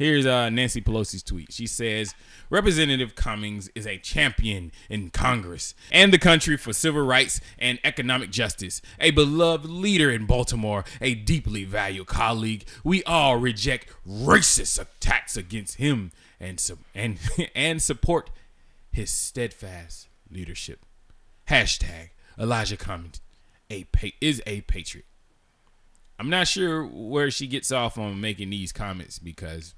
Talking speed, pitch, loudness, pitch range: 135 wpm, 110 Hz, -23 LUFS, 95-135 Hz